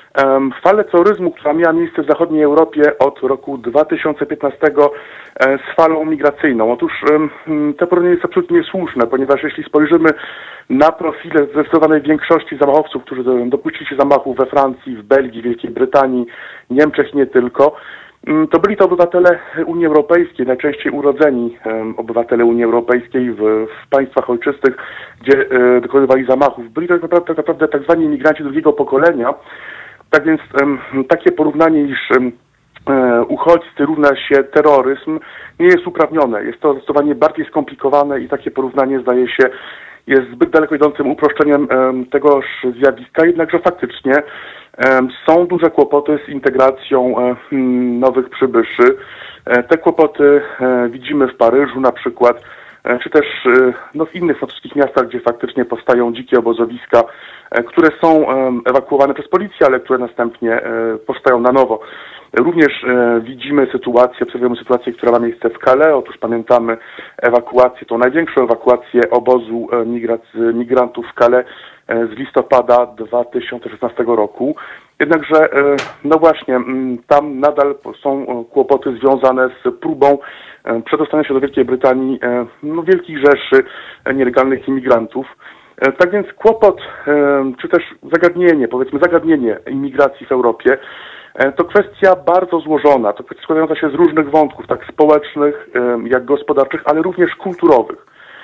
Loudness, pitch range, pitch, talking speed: -14 LUFS, 125-155 Hz, 140 Hz, 130 wpm